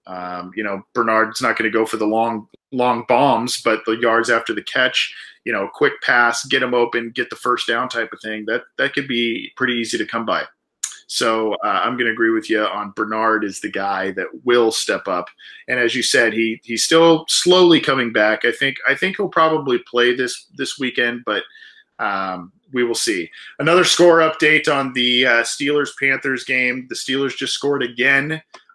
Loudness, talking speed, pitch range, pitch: -18 LUFS, 205 wpm, 110-135 Hz, 120 Hz